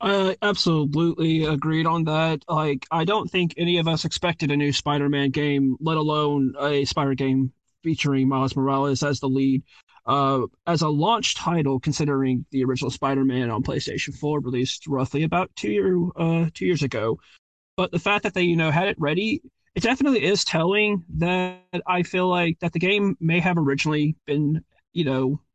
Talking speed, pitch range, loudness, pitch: 180 wpm, 140-175 Hz, -23 LUFS, 155 Hz